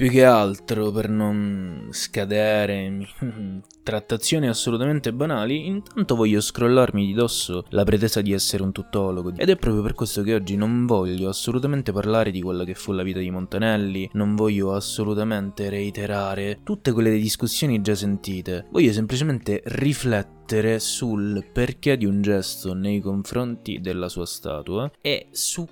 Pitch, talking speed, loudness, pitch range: 105 Hz, 145 wpm, -23 LUFS, 100-115 Hz